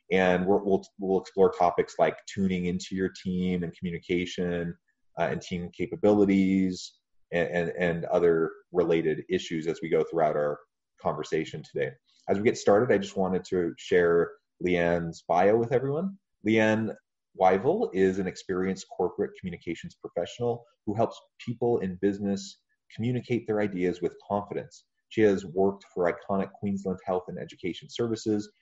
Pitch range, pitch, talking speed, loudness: 90-110 Hz, 95 Hz, 145 wpm, -28 LUFS